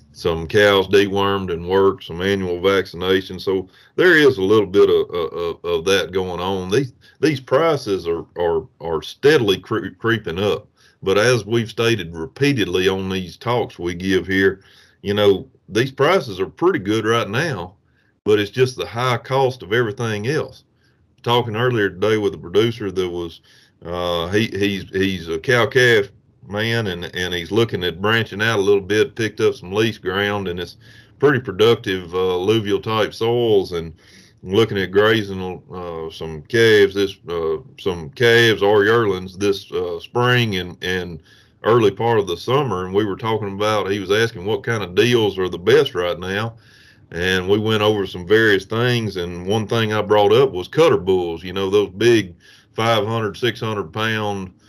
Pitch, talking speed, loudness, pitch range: 105 Hz, 180 wpm, -19 LUFS, 95-115 Hz